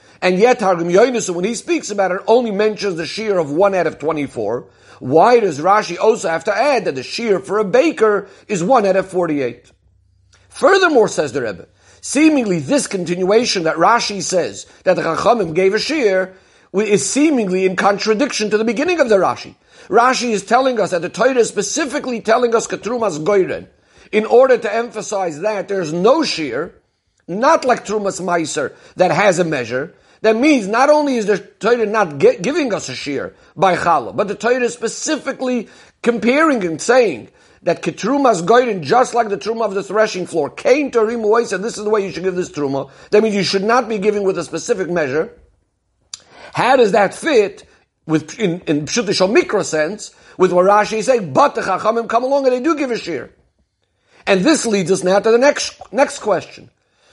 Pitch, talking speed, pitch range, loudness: 210 Hz, 195 wpm, 185-240 Hz, -16 LUFS